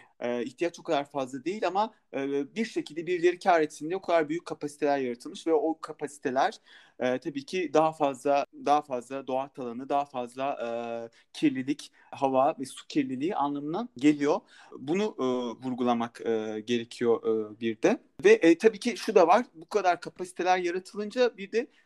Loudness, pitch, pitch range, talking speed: -28 LUFS, 150 Hz, 130-200 Hz, 150 wpm